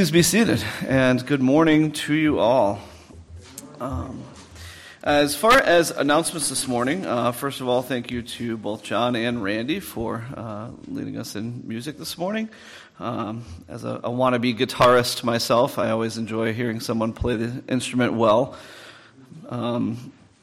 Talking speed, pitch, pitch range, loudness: 155 wpm, 120 Hz, 115-145 Hz, -22 LUFS